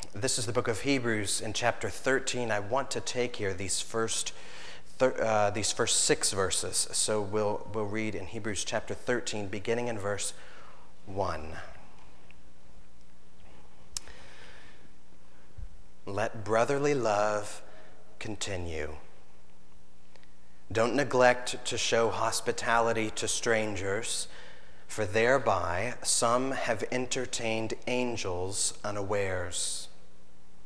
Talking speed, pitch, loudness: 100 wpm, 105 Hz, -30 LUFS